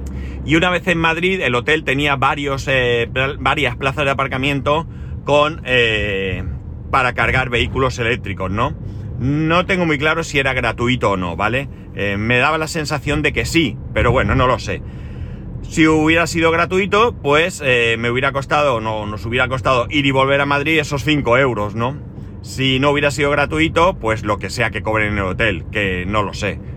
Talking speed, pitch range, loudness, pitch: 195 wpm, 110-150 Hz, -17 LUFS, 130 Hz